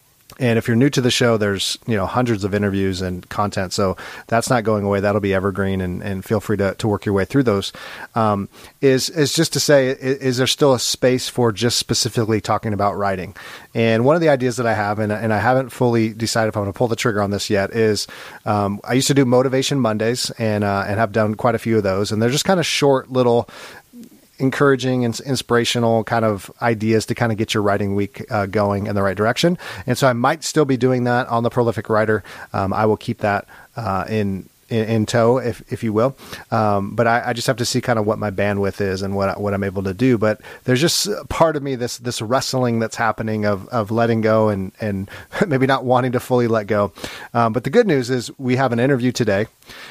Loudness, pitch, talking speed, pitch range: -19 LUFS, 115 Hz, 240 wpm, 105-125 Hz